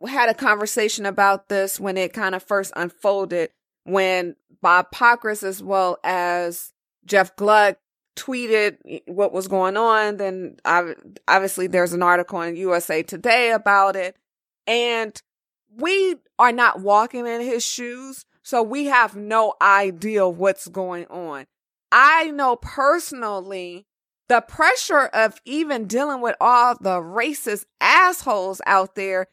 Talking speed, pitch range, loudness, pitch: 135 wpm, 185-240 Hz, -19 LUFS, 205 Hz